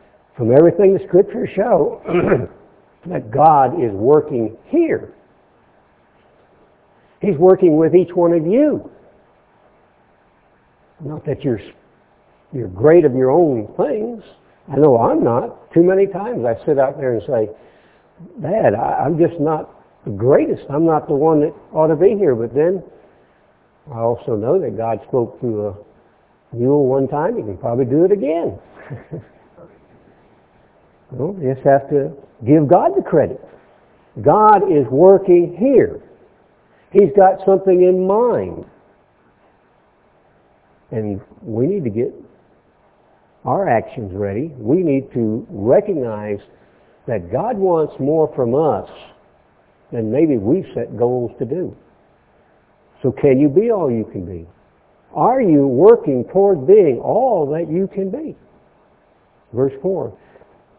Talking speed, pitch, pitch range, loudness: 135 wpm, 155 Hz, 125-190 Hz, -16 LUFS